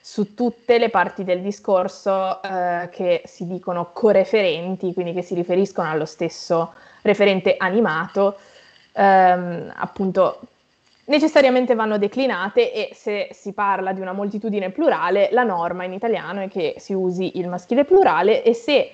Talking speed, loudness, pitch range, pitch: 145 wpm, -20 LUFS, 180-235 Hz, 195 Hz